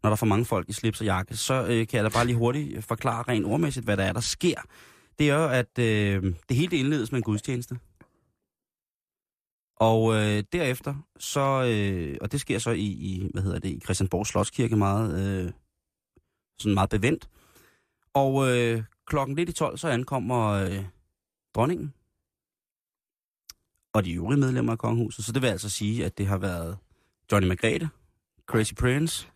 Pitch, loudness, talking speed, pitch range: 110 Hz, -26 LUFS, 180 wpm, 100-125 Hz